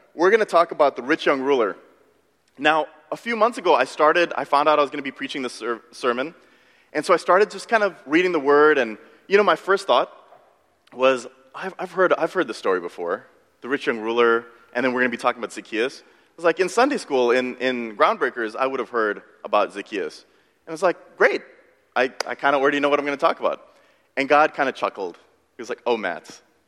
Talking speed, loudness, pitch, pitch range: 245 wpm, -21 LUFS, 155 Hz, 130-190 Hz